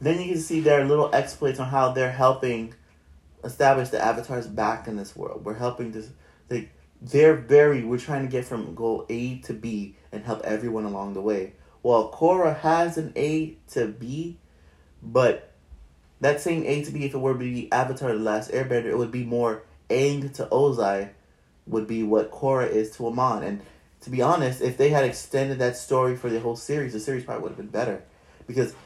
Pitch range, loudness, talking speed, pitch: 110-140 Hz, -25 LUFS, 200 wpm, 125 Hz